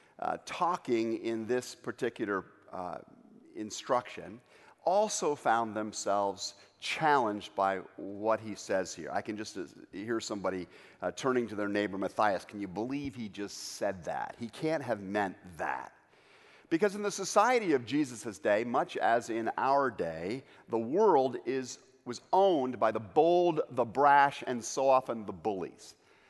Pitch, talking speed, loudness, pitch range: 115 Hz, 155 wpm, -32 LUFS, 105-145 Hz